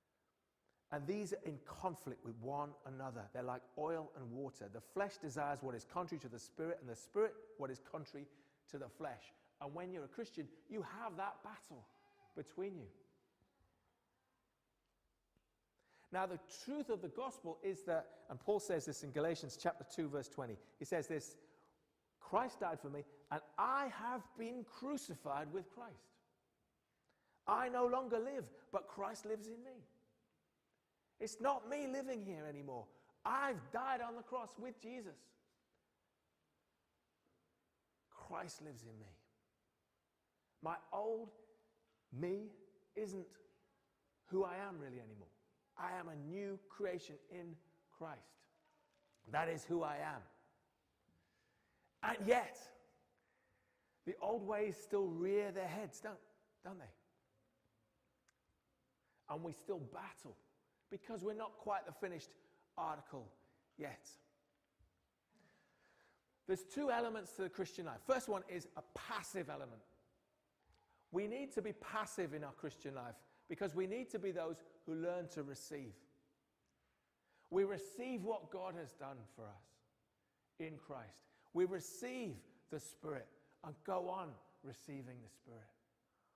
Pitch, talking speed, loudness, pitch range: 175 Hz, 135 wpm, -45 LUFS, 140-210 Hz